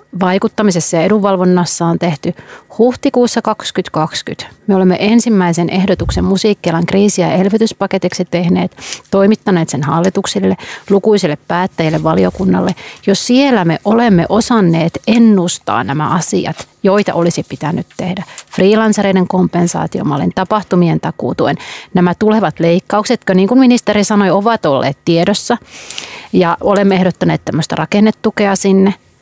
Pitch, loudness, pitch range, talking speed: 190 Hz, -12 LUFS, 170-210 Hz, 115 wpm